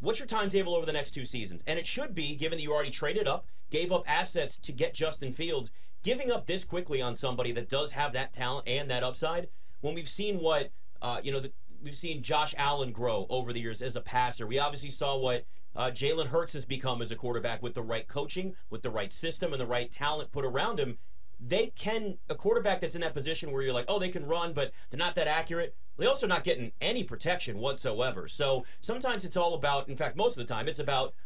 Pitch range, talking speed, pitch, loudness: 125-170 Hz, 240 wpm, 145 Hz, -32 LUFS